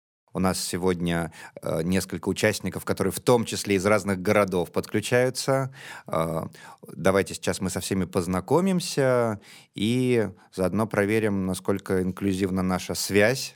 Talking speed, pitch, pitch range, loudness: 125 wpm, 95 Hz, 95-110 Hz, -25 LUFS